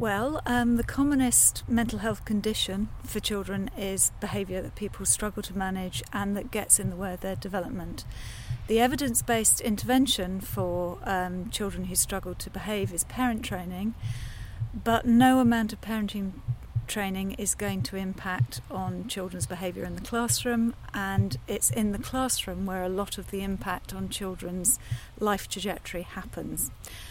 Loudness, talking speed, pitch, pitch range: -28 LUFS, 155 wpm, 195 Hz, 180-220 Hz